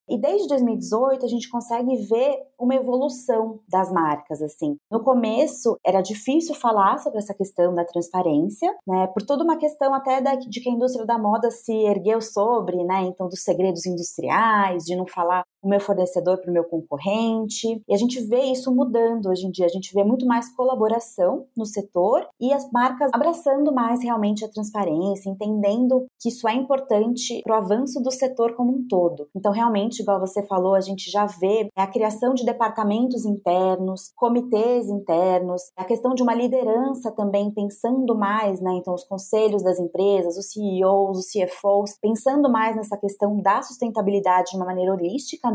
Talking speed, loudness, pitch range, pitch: 175 wpm, -22 LUFS, 190-245 Hz, 215 Hz